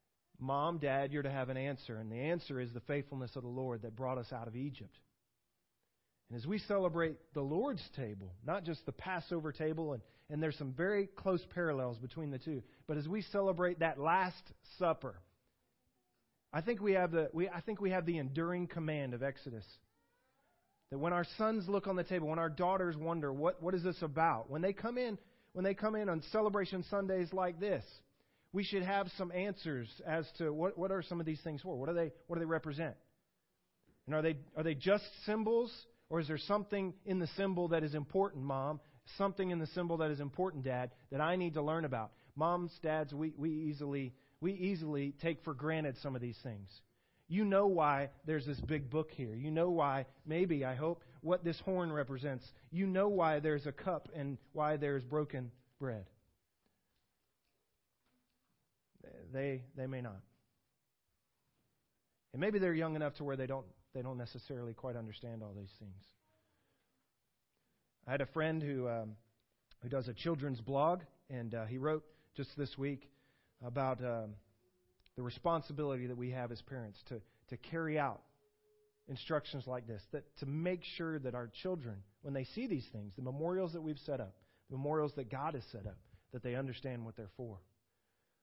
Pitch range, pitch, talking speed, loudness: 125-170 Hz, 145 Hz, 195 wpm, -39 LUFS